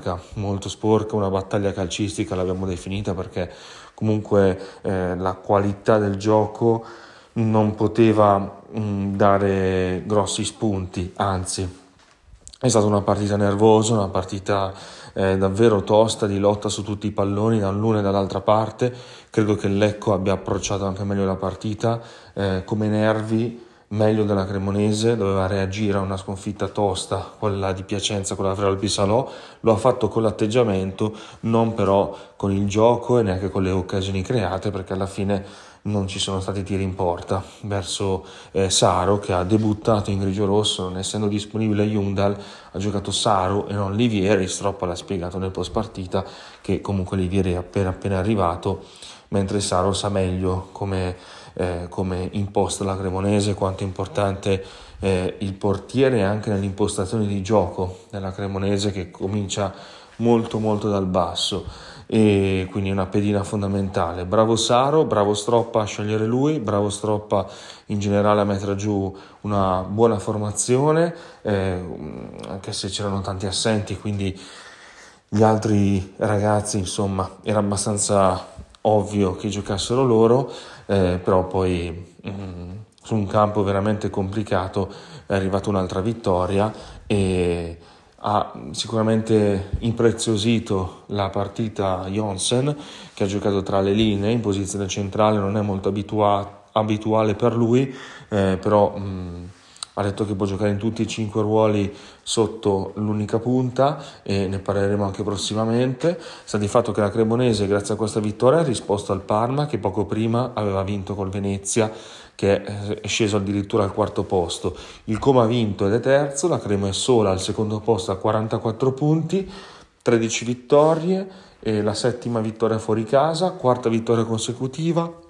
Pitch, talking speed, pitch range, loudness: 100 Hz, 145 wpm, 95-110 Hz, -22 LUFS